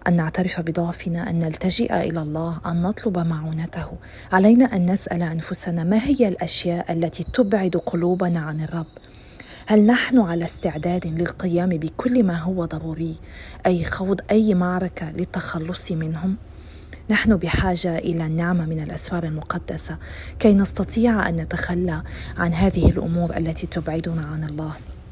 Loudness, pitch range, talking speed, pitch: -22 LUFS, 165-185 Hz, 130 wpm, 175 Hz